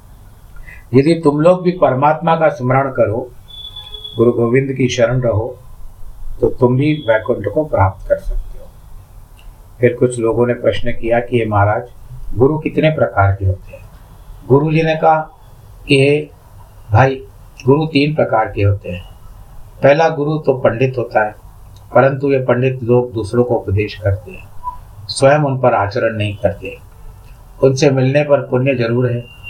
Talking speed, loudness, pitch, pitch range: 155 wpm, -15 LUFS, 120 Hz, 105-135 Hz